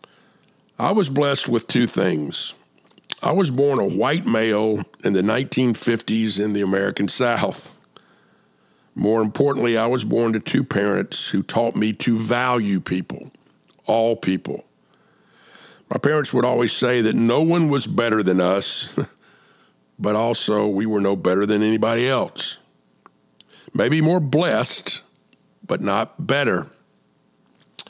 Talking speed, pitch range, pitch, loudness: 135 wpm, 105-130 Hz, 115 Hz, -20 LUFS